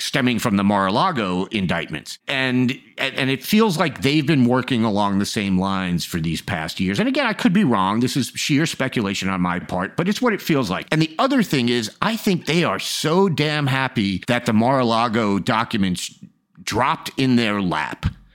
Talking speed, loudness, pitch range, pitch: 195 wpm, -20 LUFS, 100-160 Hz, 130 Hz